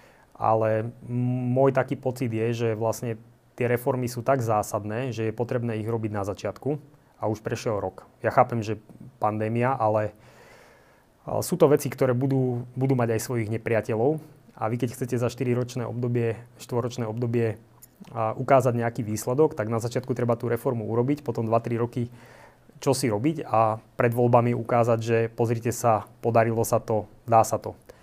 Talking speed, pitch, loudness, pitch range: 165 wpm, 120 Hz, -26 LUFS, 110-125 Hz